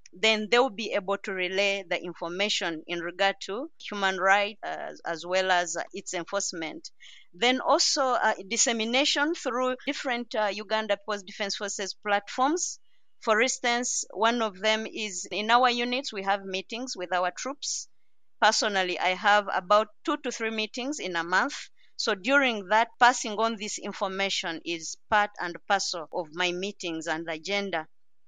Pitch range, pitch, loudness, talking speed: 185-240 Hz, 205 Hz, -27 LUFS, 160 wpm